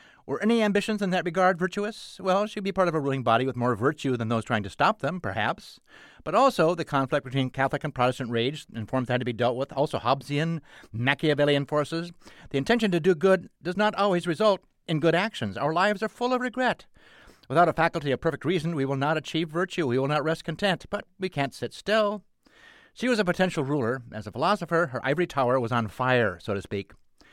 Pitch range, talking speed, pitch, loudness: 130-190 Hz, 225 wpm, 160 Hz, -26 LUFS